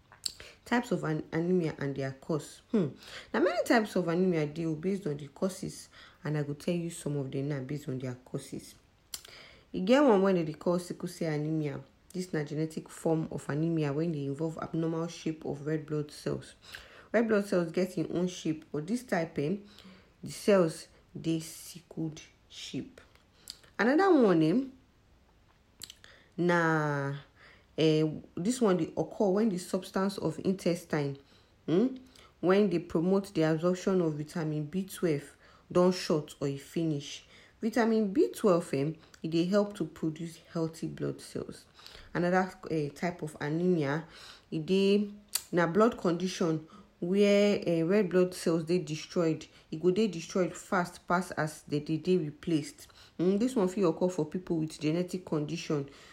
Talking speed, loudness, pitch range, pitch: 160 wpm, -31 LUFS, 155-190 Hz, 170 Hz